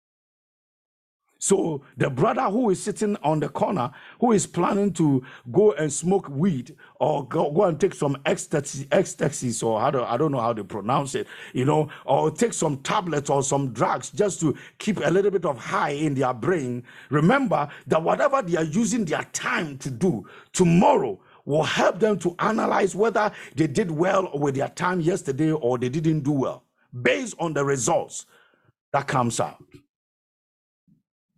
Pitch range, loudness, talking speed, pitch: 140-195 Hz, -24 LUFS, 175 wpm, 160 Hz